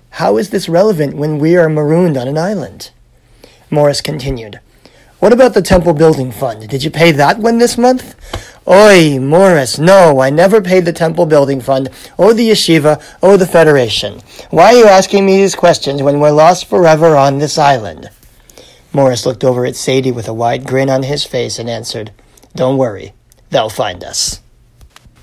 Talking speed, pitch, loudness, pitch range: 180 wpm, 150 Hz, -10 LUFS, 130-175 Hz